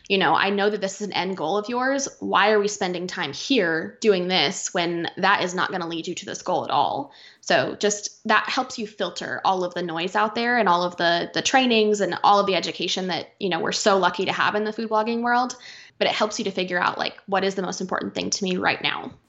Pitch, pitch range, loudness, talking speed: 200 Hz, 180-215 Hz, -23 LUFS, 270 wpm